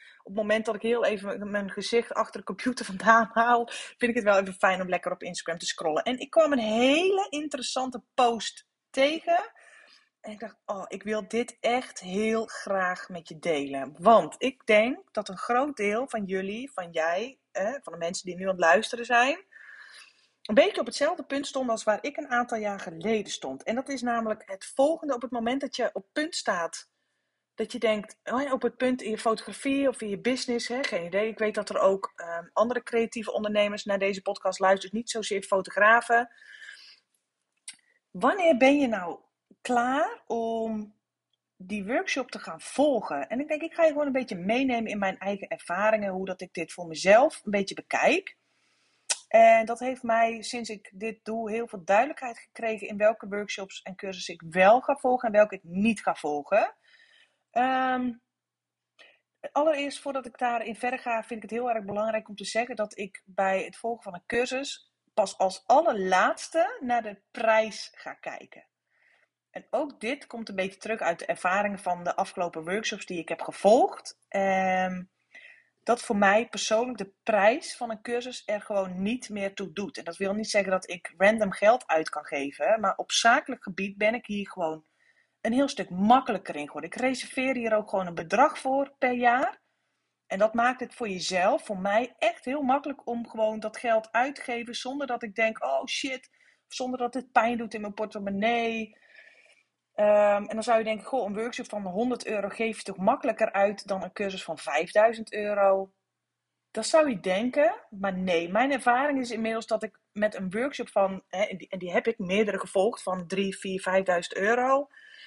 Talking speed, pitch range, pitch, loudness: 195 wpm, 195-255 Hz, 225 Hz, -27 LUFS